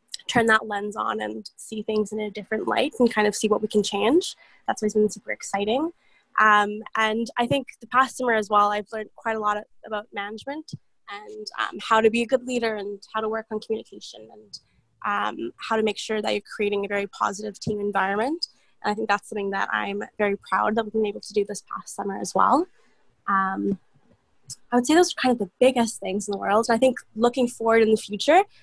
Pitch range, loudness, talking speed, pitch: 205-240 Hz, -24 LUFS, 230 wpm, 215 Hz